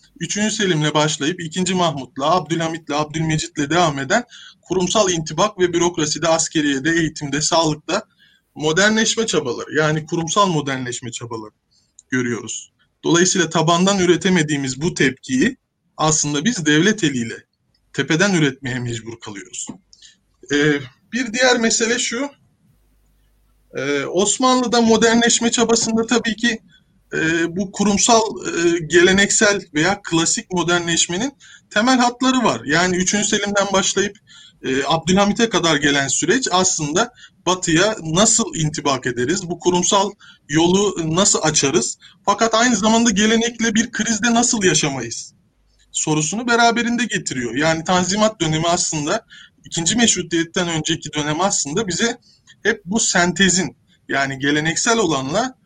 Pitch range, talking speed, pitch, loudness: 155-215 Hz, 110 wpm, 175 Hz, -17 LUFS